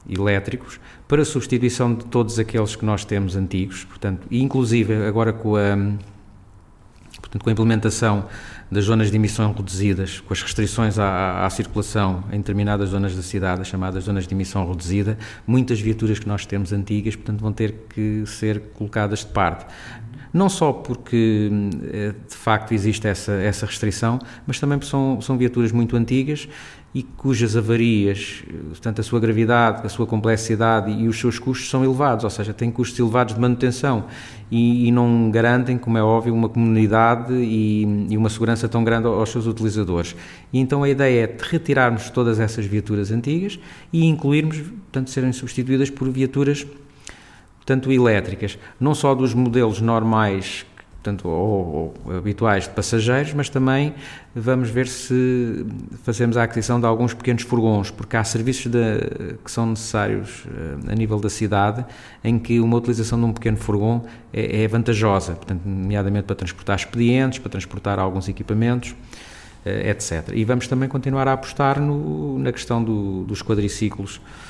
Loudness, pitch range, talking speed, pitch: -21 LUFS, 105-125 Hz, 160 wpm, 115 Hz